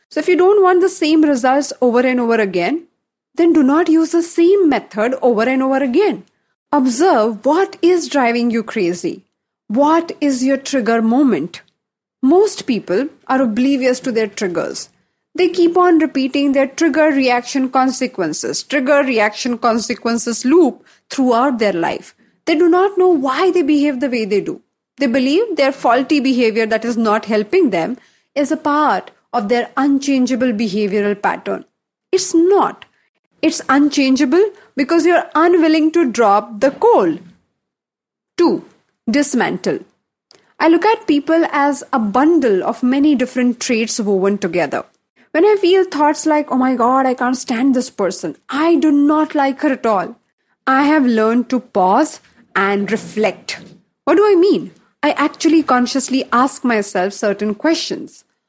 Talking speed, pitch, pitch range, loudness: 155 wpm, 275 Hz, 240-320 Hz, -15 LUFS